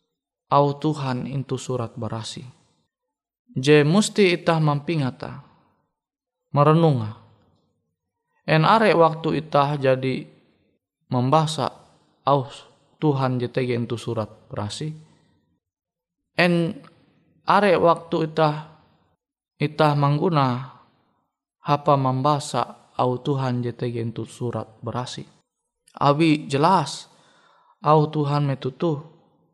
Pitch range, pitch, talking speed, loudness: 125-155 Hz, 140 Hz, 85 wpm, -22 LUFS